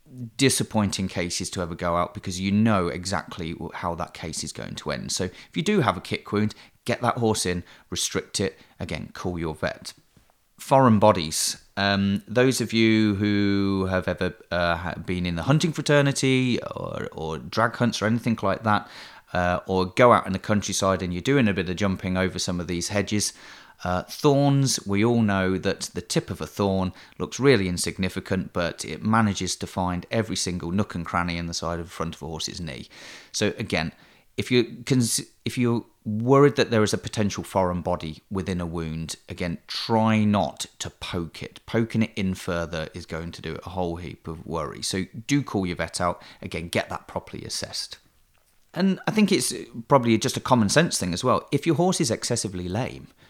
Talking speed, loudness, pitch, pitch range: 200 wpm, -25 LUFS, 100 Hz, 90-115 Hz